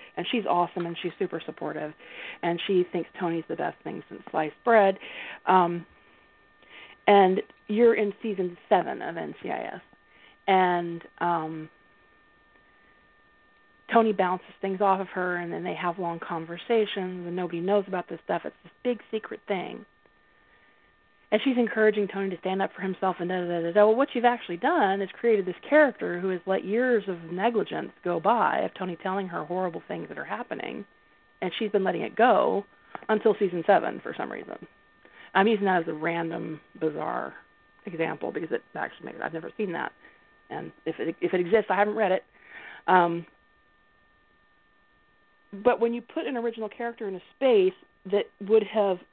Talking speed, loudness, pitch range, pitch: 175 wpm, -27 LUFS, 175-215 Hz, 190 Hz